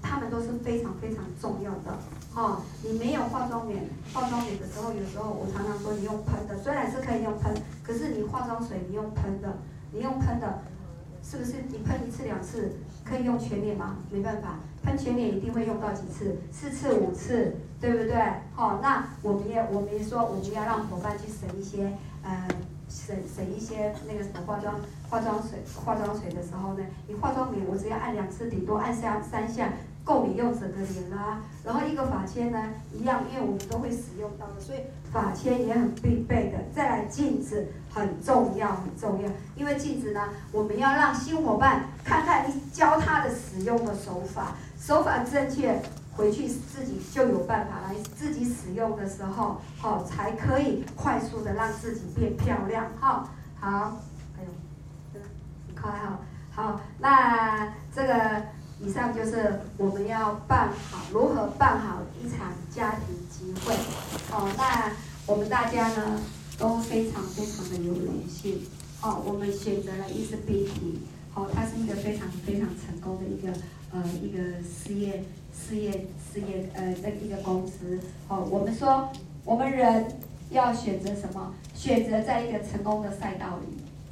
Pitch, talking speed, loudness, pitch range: 210 Hz, 255 characters per minute, -29 LUFS, 195-230 Hz